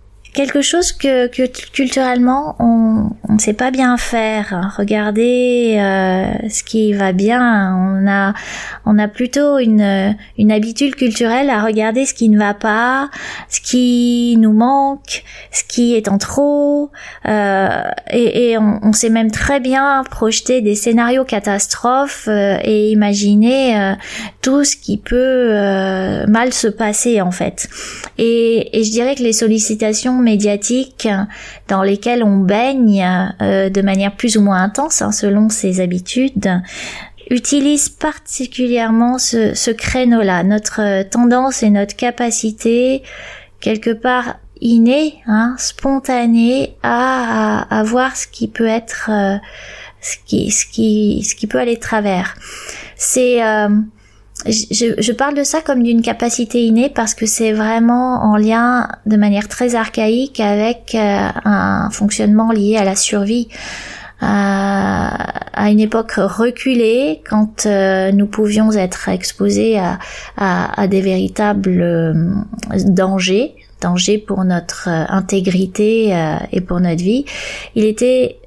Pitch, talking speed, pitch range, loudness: 225 Hz, 140 wpm, 205-245 Hz, -14 LUFS